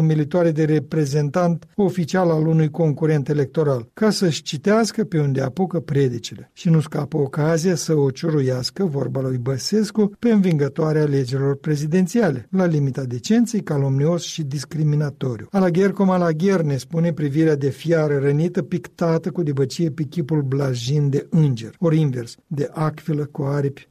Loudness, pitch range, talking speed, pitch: -20 LUFS, 140-175 Hz, 145 wpm, 155 Hz